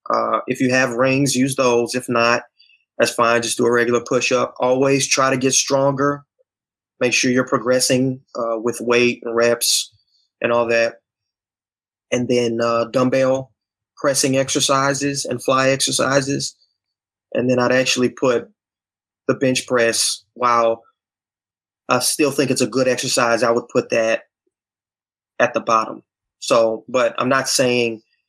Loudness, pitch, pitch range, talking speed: -18 LUFS, 125 Hz, 115-130 Hz, 150 wpm